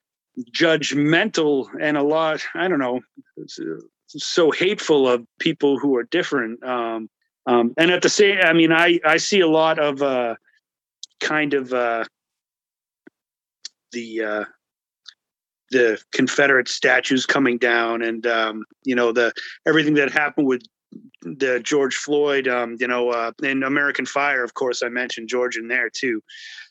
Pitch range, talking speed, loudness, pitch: 120-160 Hz, 150 wpm, -20 LUFS, 140 Hz